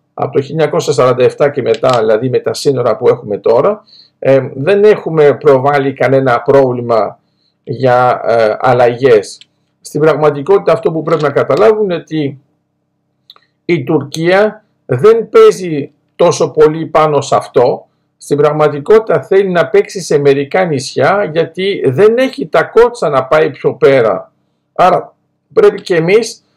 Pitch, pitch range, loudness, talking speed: 165 Hz, 145-220 Hz, -11 LUFS, 135 wpm